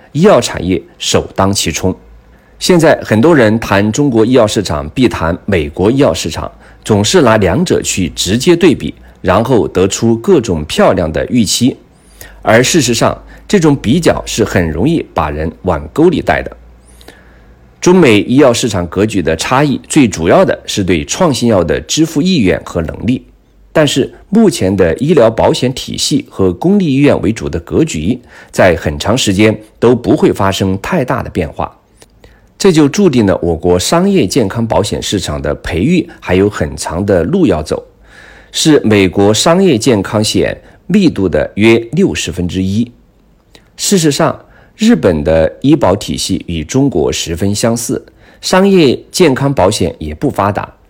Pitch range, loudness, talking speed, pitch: 85-125 Hz, -11 LUFS, 240 characters per minute, 100 Hz